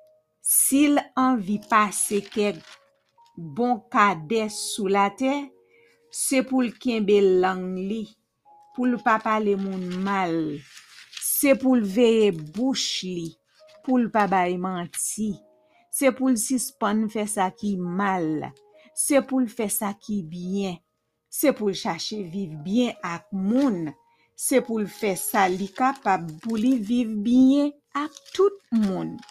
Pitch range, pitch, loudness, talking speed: 190-260 Hz, 215 Hz, -24 LUFS, 145 wpm